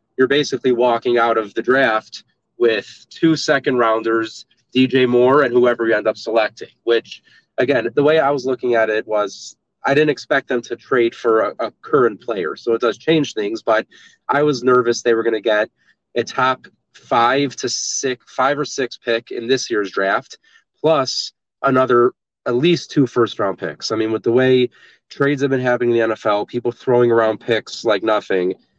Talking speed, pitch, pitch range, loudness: 195 wpm, 125 Hz, 115-135 Hz, -18 LUFS